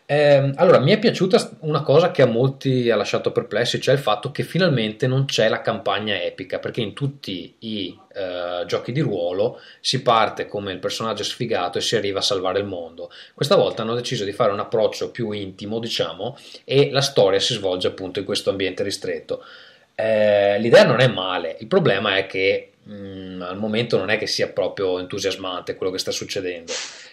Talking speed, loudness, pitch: 190 wpm, -21 LUFS, 145 Hz